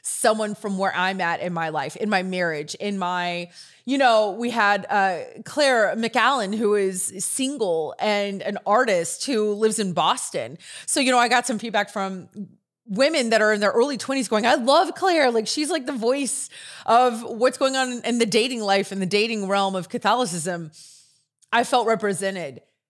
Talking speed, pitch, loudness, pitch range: 185 wpm, 215 Hz, -22 LUFS, 195-250 Hz